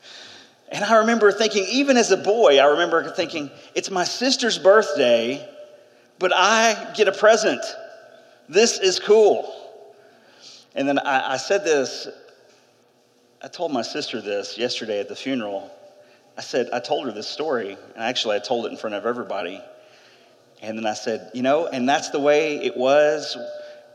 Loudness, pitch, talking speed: -20 LUFS, 185 Hz, 165 wpm